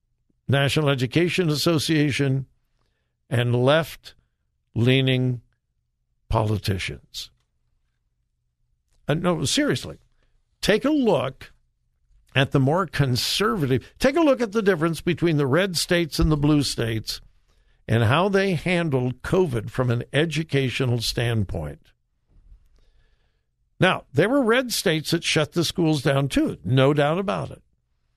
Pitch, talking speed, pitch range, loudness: 135 Hz, 115 wpm, 115-165 Hz, -22 LUFS